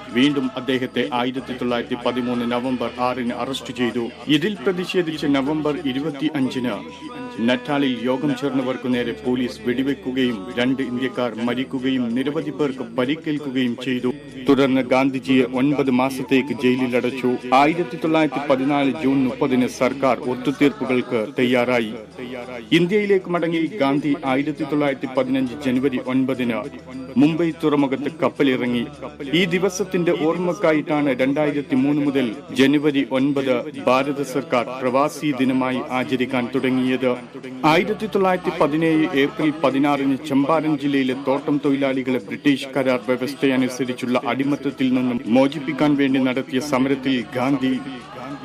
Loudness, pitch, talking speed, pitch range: -21 LUFS, 135 Hz, 105 wpm, 125-150 Hz